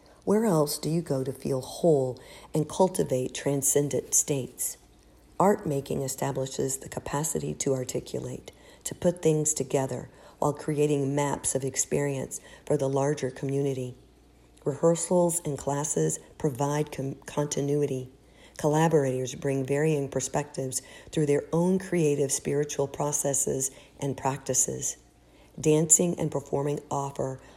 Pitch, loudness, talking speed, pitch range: 140 Hz, -27 LUFS, 120 wpm, 135-150 Hz